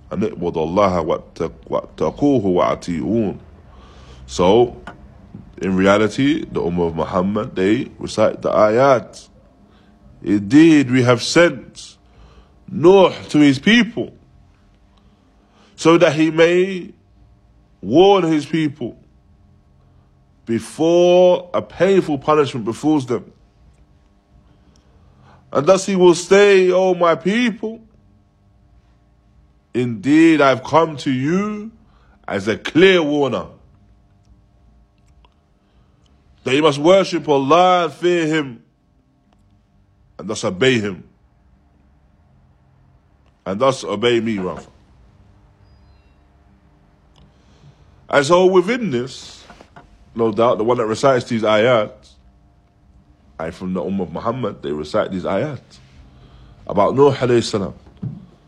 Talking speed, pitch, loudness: 95 wpm, 105 Hz, -16 LUFS